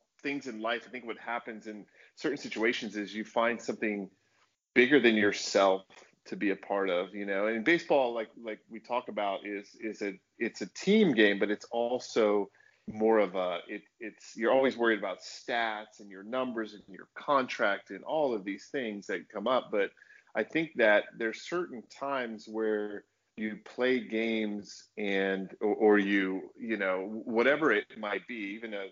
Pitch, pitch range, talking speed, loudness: 110 Hz, 100-120 Hz, 185 wpm, -31 LUFS